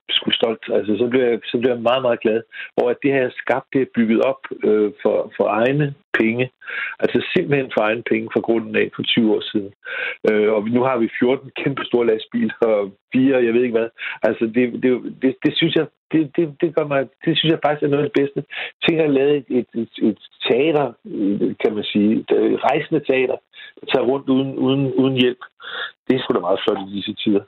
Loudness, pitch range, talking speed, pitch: -19 LUFS, 115-145 Hz, 225 wpm, 130 Hz